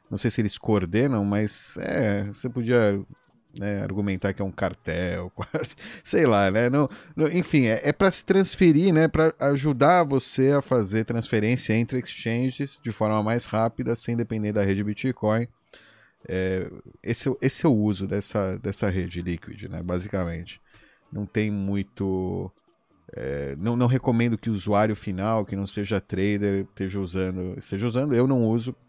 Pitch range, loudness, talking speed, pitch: 100-125 Hz, -25 LUFS, 165 wpm, 110 Hz